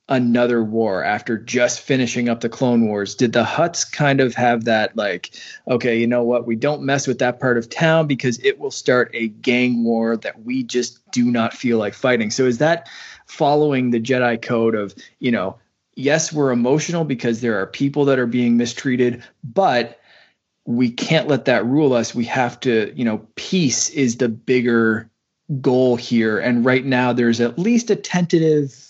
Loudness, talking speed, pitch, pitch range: -19 LUFS, 190 wpm, 125 Hz, 115-135 Hz